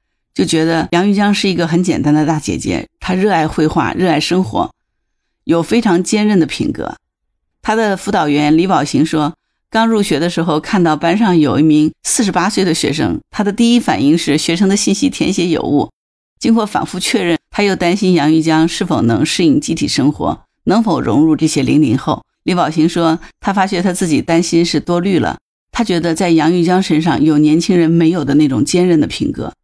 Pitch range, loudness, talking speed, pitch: 160-195 Hz, -13 LUFS, 300 characters per minute, 170 Hz